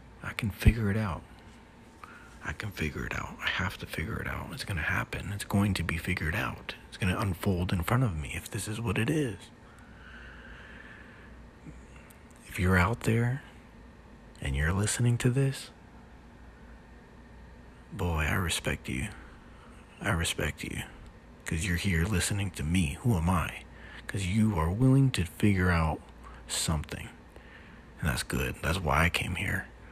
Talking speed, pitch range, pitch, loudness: 160 wpm, 85-110 Hz, 95 Hz, -30 LUFS